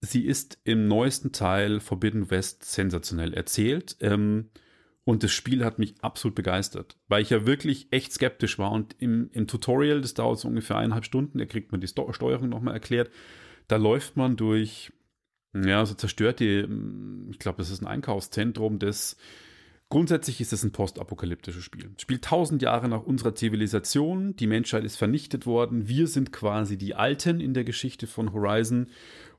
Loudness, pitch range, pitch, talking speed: -27 LUFS, 105-125 Hz, 110 Hz, 165 wpm